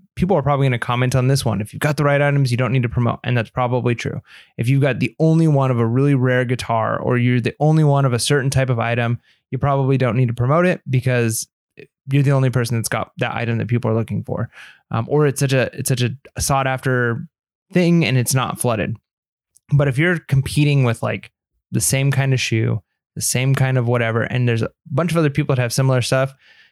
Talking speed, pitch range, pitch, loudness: 245 wpm, 120-140 Hz, 130 Hz, -18 LUFS